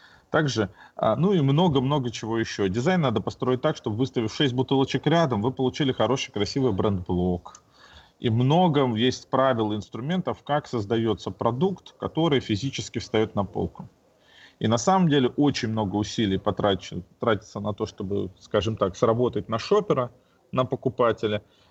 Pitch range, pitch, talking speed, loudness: 110-135 Hz, 120 Hz, 145 wpm, -25 LUFS